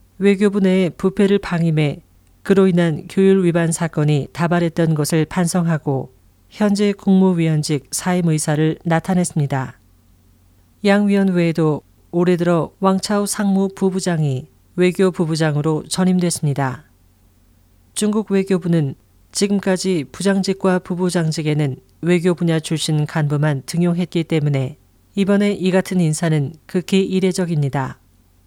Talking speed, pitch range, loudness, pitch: 285 characters per minute, 150-190 Hz, -18 LUFS, 170 Hz